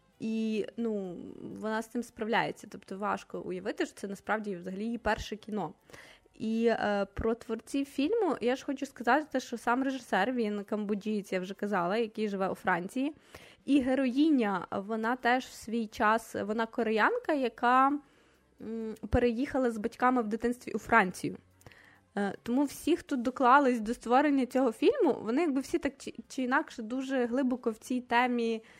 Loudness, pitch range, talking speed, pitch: -31 LUFS, 215-260 Hz, 155 wpm, 235 Hz